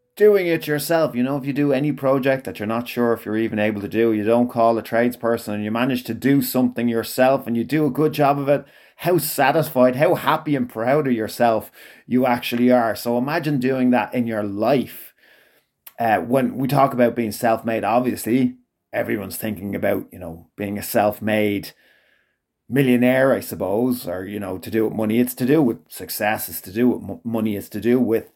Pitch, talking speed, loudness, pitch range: 120 Hz, 205 wpm, -20 LUFS, 110-135 Hz